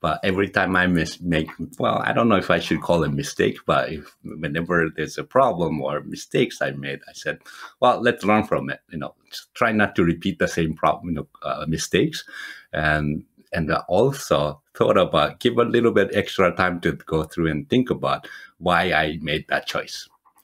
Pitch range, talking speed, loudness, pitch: 75-95 Hz, 200 wpm, -22 LUFS, 80 Hz